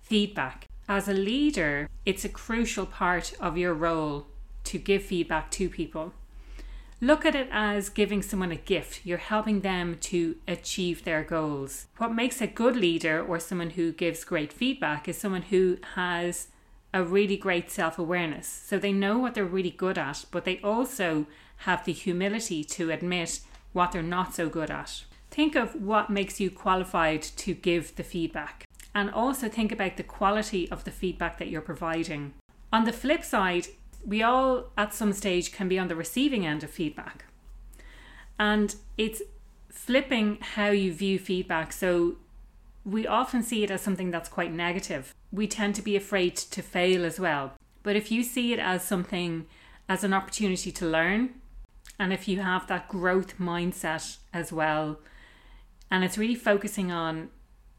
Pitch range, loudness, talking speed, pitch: 170-205 Hz, -28 LUFS, 170 wpm, 185 Hz